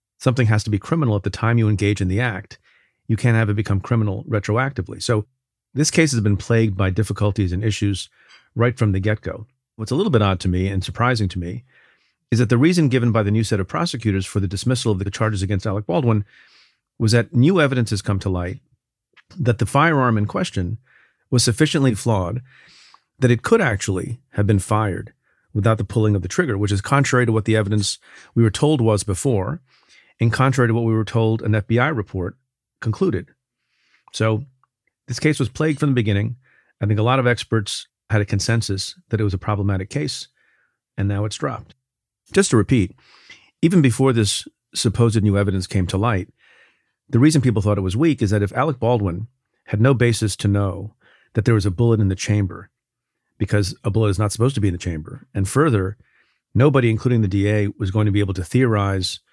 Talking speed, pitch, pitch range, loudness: 210 wpm, 110 Hz, 100-125 Hz, -20 LUFS